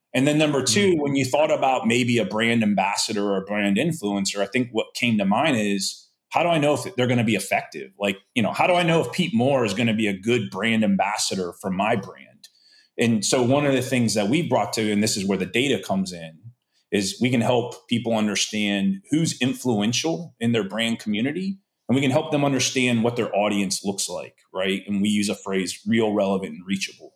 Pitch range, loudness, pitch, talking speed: 100-130 Hz, -22 LUFS, 115 Hz, 230 wpm